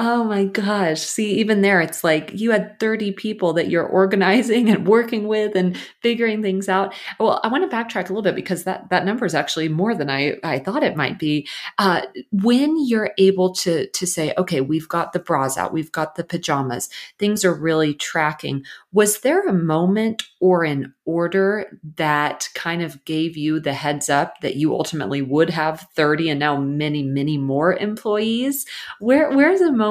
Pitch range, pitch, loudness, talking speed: 155-210 Hz, 180 Hz, -20 LUFS, 195 wpm